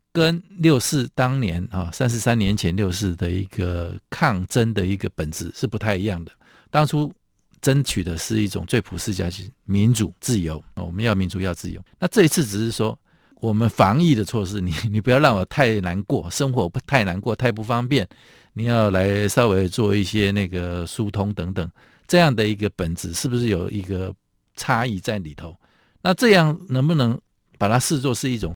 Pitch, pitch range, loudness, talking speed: 110 Hz, 95-125 Hz, -21 LUFS, 275 characters per minute